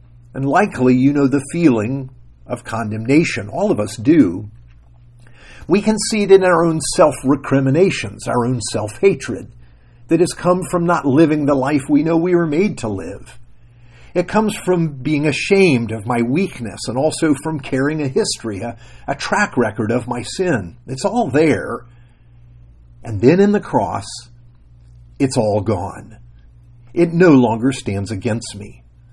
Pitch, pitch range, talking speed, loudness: 125 Hz, 110-155 Hz, 160 wpm, -17 LUFS